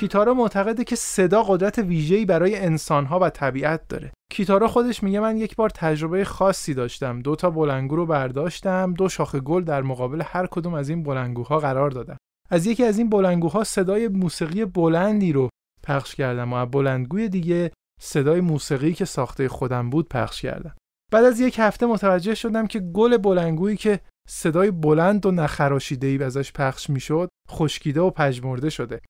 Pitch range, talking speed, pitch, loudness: 140-200 Hz, 170 wpm, 170 Hz, -22 LUFS